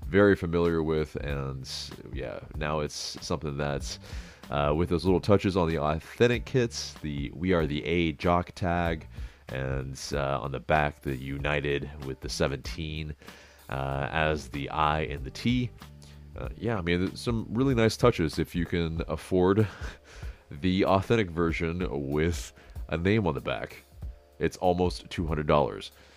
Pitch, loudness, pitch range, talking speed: 80 Hz, -29 LUFS, 75-90 Hz, 150 wpm